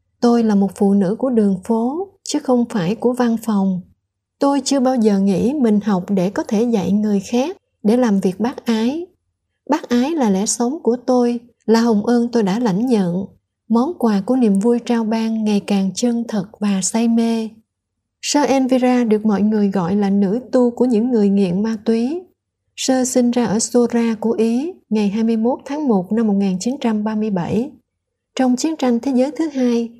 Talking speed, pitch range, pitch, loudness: 190 wpm, 210-250 Hz, 230 Hz, -17 LUFS